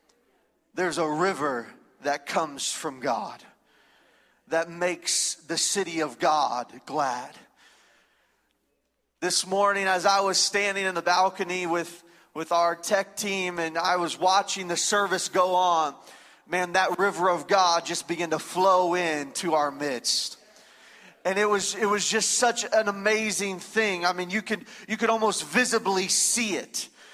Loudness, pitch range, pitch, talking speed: -25 LUFS, 170-200 Hz, 185 Hz, 150 wpm